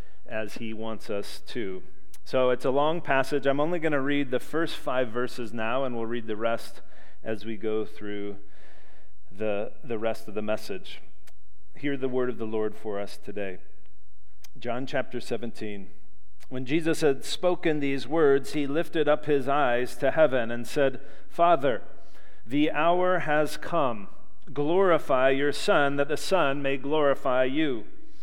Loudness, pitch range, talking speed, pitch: -27 LUFS, 105-145 Hz, 160 wpm, 125 Hz